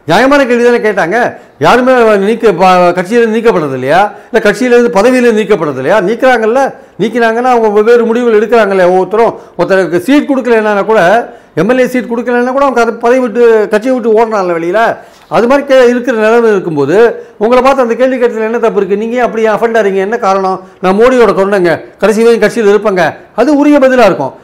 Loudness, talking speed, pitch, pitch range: -8 LUFS, 165 wpm, 230 Hz, 205-245 Hz